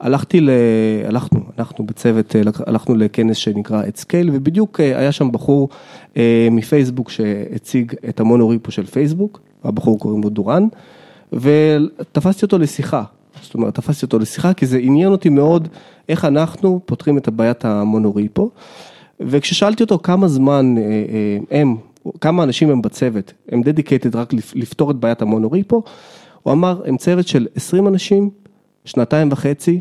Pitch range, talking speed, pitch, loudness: 115-165 Hz, 135 wpm, 140 Hz, -16 LUFS